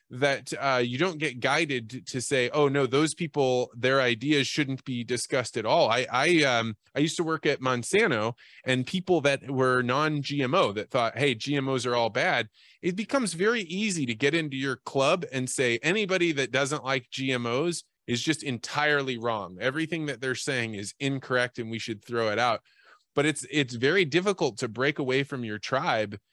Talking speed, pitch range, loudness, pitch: 190 wpm, 125-150 Hz, -27 LUFS, 135 Hz